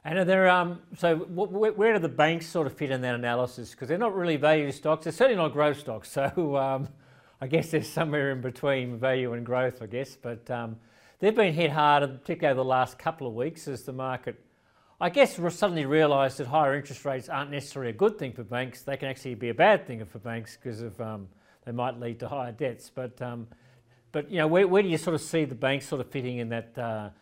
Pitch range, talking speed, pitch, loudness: 125-165 Hz, 240 wpm, 135 Hz, -27 LUFS